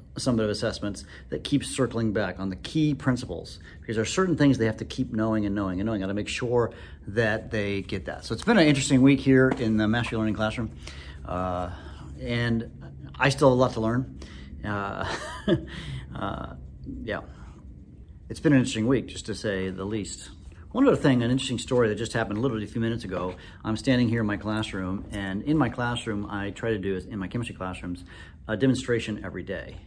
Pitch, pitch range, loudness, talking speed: 110 Hz, 90-120 Hz, -26 LUFS, 205 wpm